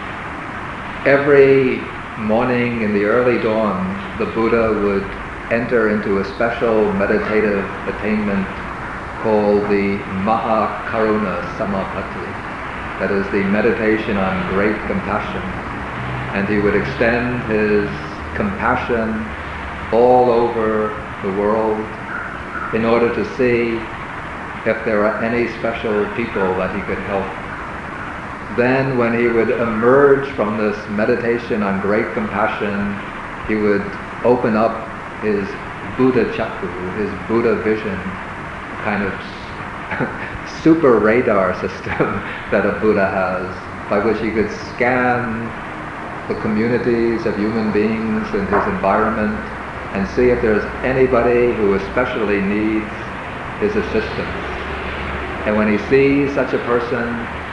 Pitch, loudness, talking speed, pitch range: 110 Hz, -18 LUFS, 115 wpm, 100-120 Hz